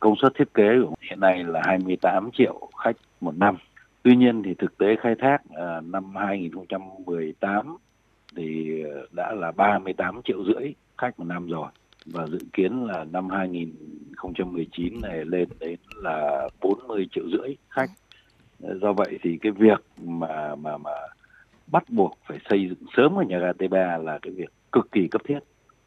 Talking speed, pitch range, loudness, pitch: 165 wpm, 85-100 Hz, -25 LUFS, 90 Hz